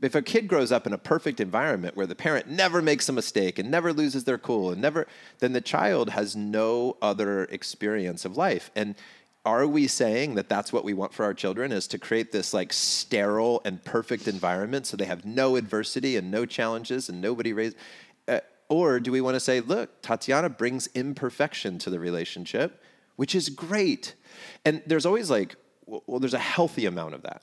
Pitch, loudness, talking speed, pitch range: 125 Hz, -27 LUFS, 200 wpm, 105-140 Hz